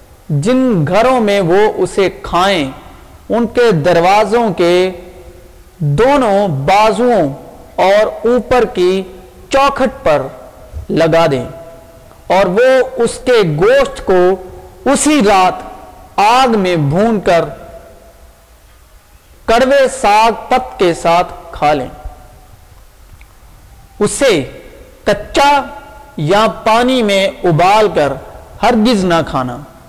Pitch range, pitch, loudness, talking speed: 170-245 Hz, 205 Hz, -12 LUFS, 95 wpm